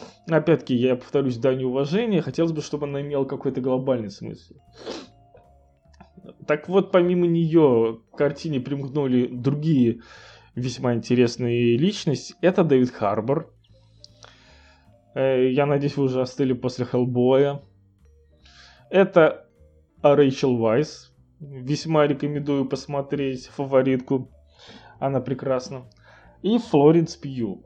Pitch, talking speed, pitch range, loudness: 130 Hz, 100 wpm, 120-145 Hz, -22 LUFS